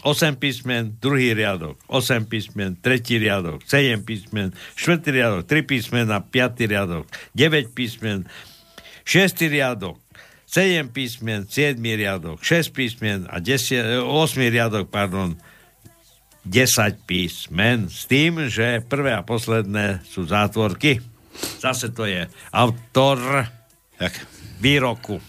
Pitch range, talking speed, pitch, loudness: 105-130 Hz, 115 wpm, 115 Hz, -21 LUFS